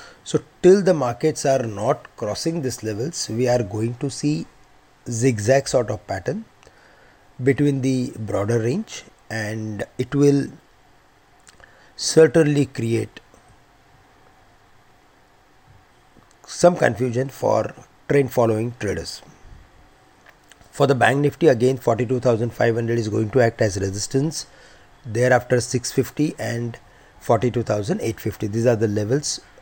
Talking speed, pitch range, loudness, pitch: 115 wpm, 110-140 Hz, -21 LUFS, 125 Hz